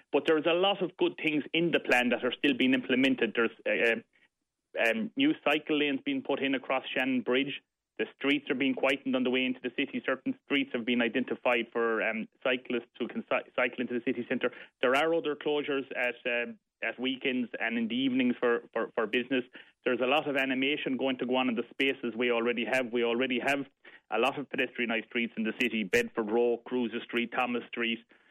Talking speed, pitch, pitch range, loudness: 215 wpm, 130 Hz, 120-140 Hz, -30 LUFS